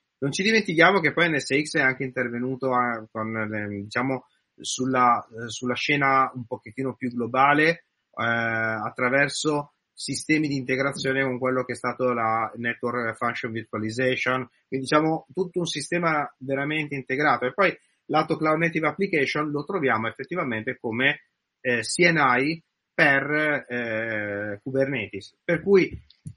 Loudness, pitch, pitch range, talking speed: -24 LUFS, 130 Hz, 120-150 Hz, 125 wpm